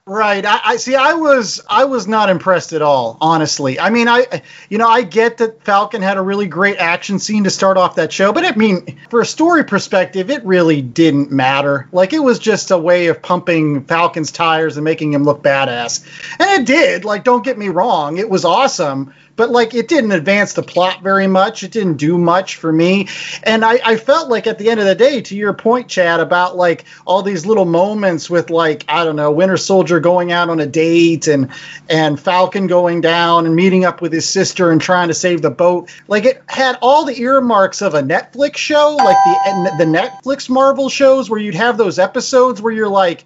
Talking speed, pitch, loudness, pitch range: 220 wpm, 190 Hz, -13 LUFS, 170-230 Hz